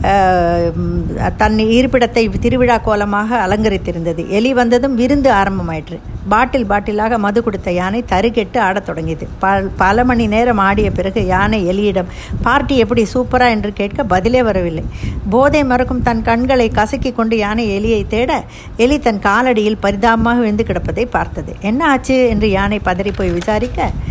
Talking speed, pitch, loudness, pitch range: 135 wpm, 220 Hz, -14 LUFS, 195-245 Hz